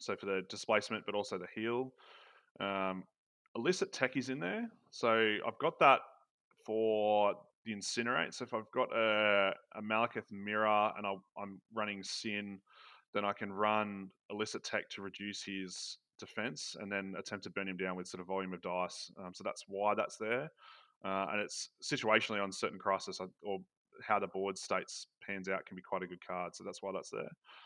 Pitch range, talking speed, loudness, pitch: 95-105 Hz, 195 wpm, -37 LUFS, 100 Hz